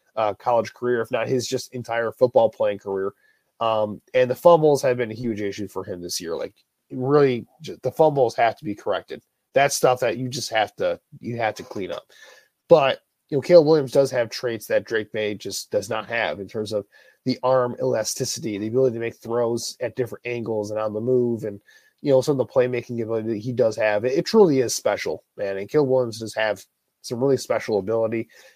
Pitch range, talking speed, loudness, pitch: 110-130 Hz, 220 wpm, -22 LUFS, 120 Hz